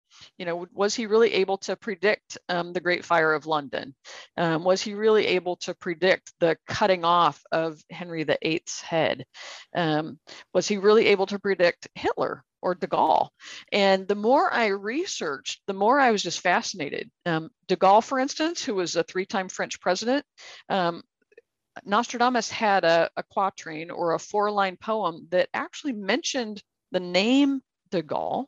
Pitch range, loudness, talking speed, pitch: 175-220 Hz, -25 LUFS, 170 wpm, 195 Hz